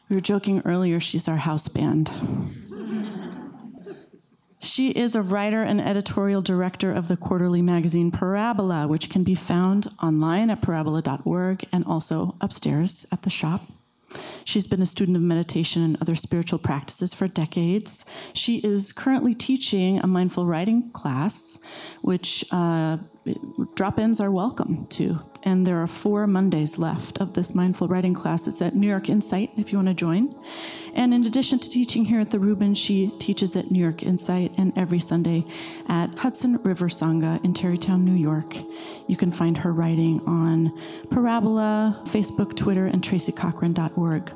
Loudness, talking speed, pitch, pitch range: -23 LUFS, 160 wpm, 185 Hz, 170-205 Hz